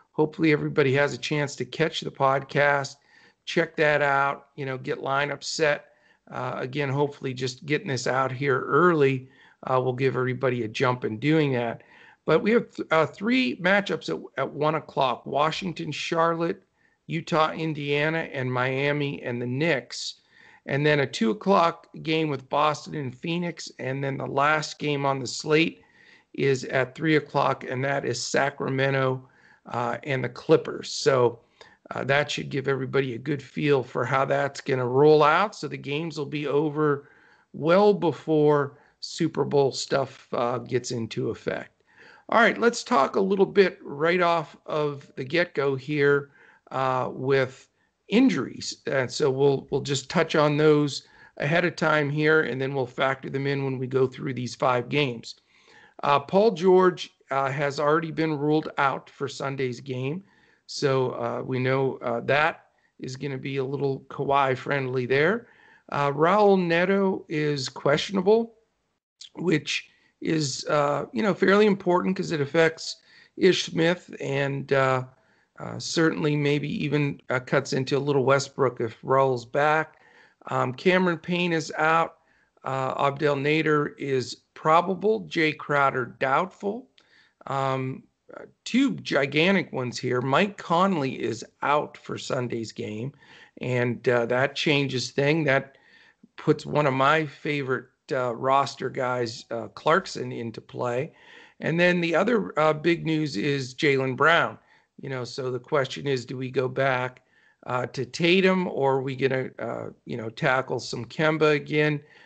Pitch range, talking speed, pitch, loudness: 130-160 Hz, 155 wpm, 145 Hz, -25 LUFS